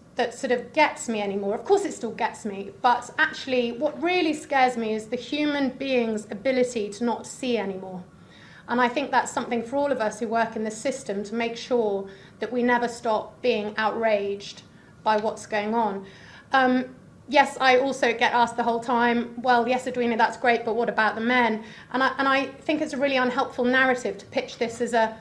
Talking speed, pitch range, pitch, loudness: 210 wpm, 220-260 Hz, 240 Hz, -24 LUFS